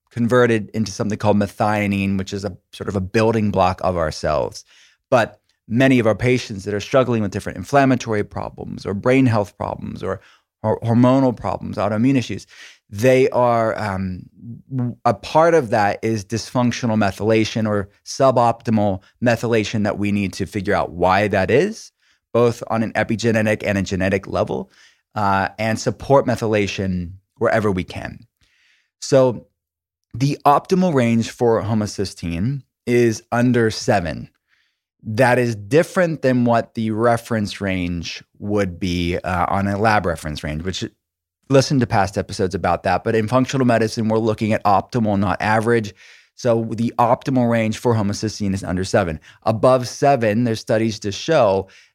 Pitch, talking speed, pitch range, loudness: 110 Hz, 150 wpm, 100-120 Hz, -19 LUFS